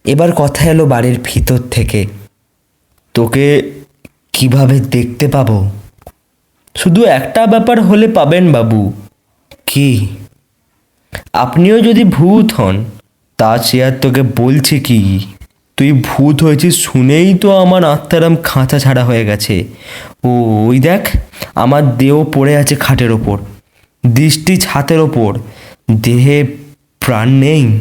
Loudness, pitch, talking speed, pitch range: -10 LUFS, 130 Hz, 110 wpm, 110-145 Hz